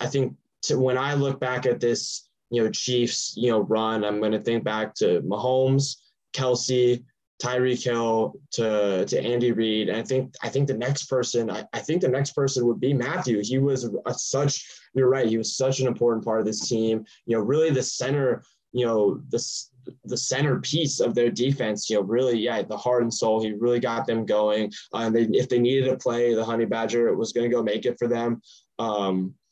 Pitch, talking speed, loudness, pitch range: 120 Hz, 220 wpm, -24 LUFS, 110-130 Hz